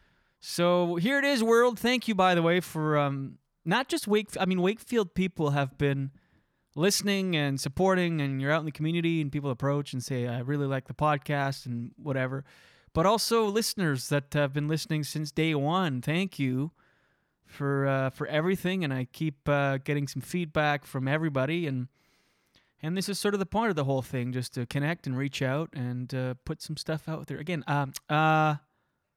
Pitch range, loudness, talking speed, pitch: 140-175 Hz, -28 LUFS, 190 wpm, 150 Hz